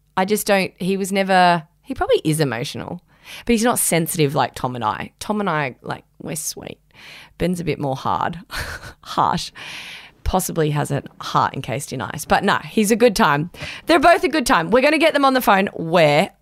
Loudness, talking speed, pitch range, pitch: -19 LUFS, 205 wpm, 150-235 Hz, 185 Hz